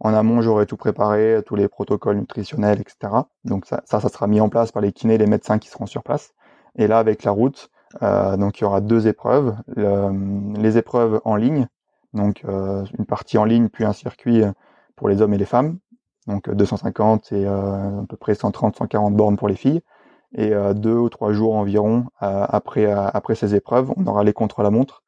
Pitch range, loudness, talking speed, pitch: 100-115 Hz, -20 LUFS, 210 wpm, 105 Hz